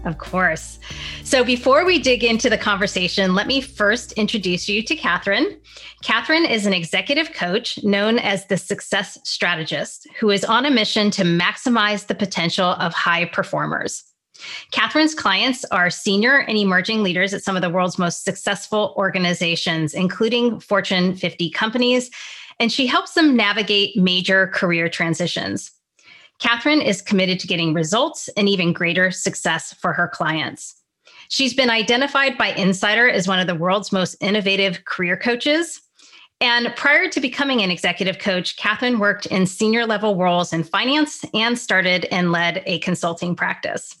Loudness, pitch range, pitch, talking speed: -18 LUFS, 180-235 Hz, 200 Hz, 155 wpm